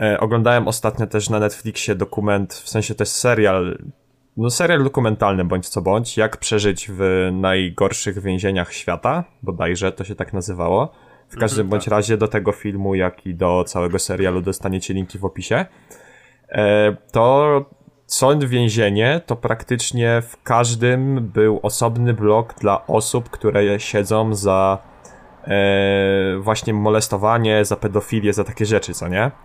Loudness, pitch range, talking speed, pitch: -19 LUFS, 95-115 Hz, 140 wpm, 105 Hz